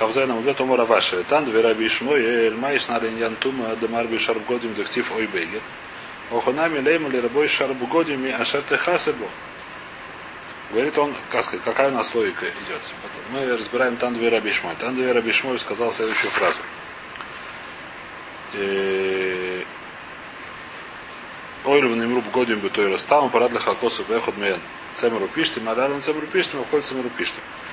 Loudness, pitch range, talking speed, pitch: -21 LUFS, 115-135 Hz, 155 wpm, 125 Hz